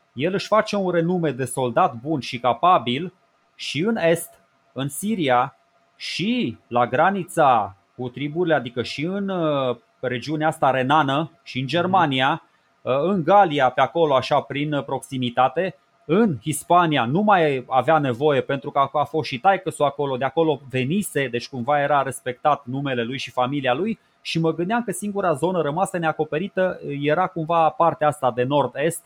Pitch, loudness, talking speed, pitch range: 150 Hz, -21 LUFS, 155 wpm, 130-170 Hz